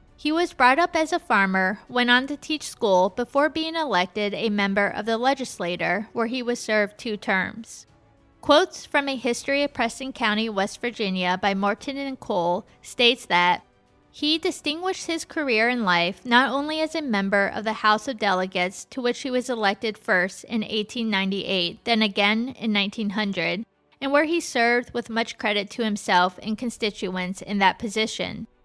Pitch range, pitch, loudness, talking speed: 200-265 Hz, 225 Hz, -23 LUFS, 175 wpm